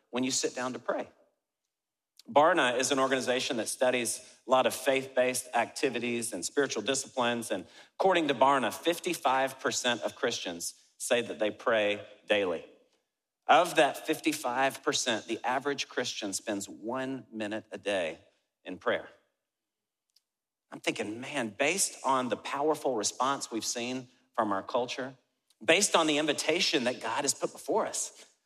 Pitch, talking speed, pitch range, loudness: 130 Hz, 145 wpm, 120-145 Hz, -30 LUFS